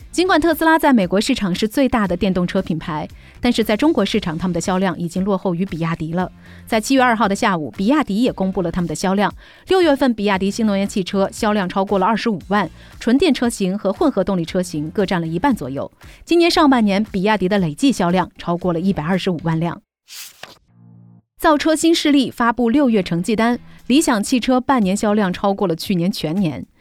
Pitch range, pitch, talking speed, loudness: 180-245 Hz, 200 Hz, 330 characters per minute, -18 LUFS